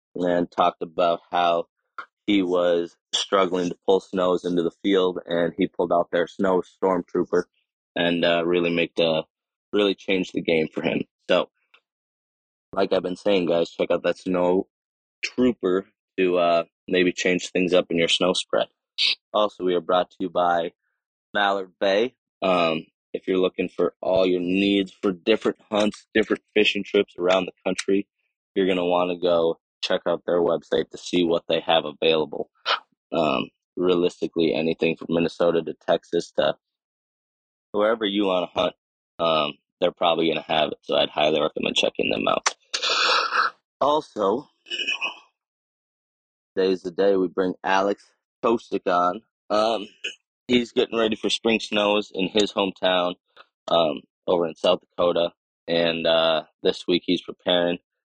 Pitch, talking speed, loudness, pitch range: 90 Hz, 155 wpm, -23 LUFS, 85-95 Hz